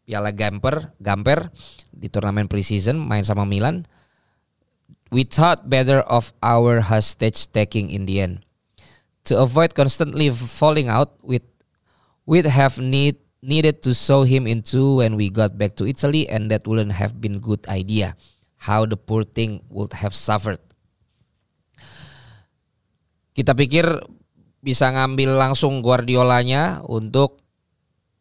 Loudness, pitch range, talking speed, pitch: -19 LUFS, 105-135 Hz, 130 wpm, 120 Hz